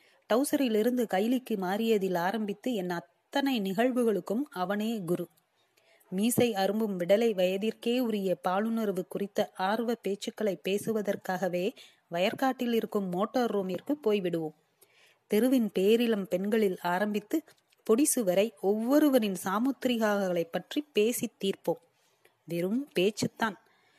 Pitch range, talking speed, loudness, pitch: 190-240 Hz, 90 wpm, -29 LUFS, 210 Hz